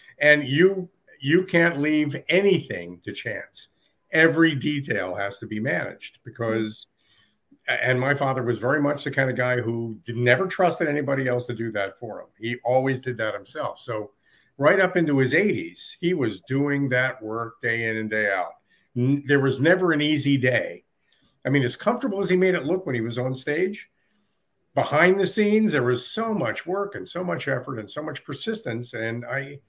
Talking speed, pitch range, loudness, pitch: 190 wpm, 120-165 Hz, -23 LUFS, 135 Hz